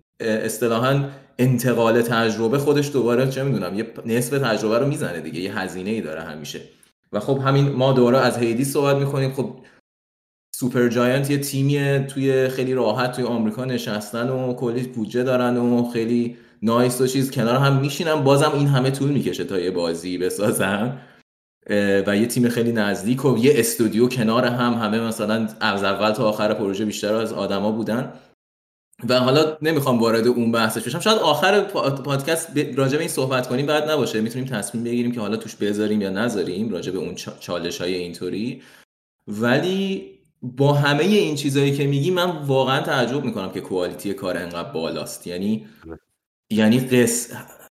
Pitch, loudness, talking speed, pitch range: 120 Hz, -21 LUFS, 165 wpm, 110-135 Hz